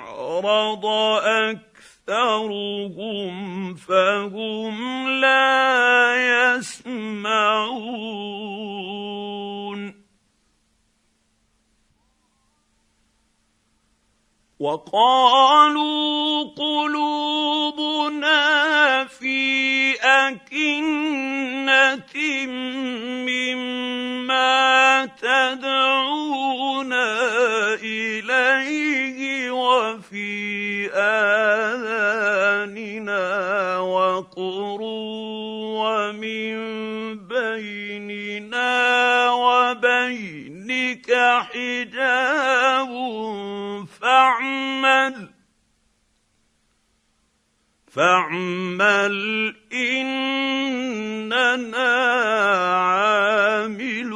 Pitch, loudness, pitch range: 245 Hz, -20 LUFS, 210-265 Hz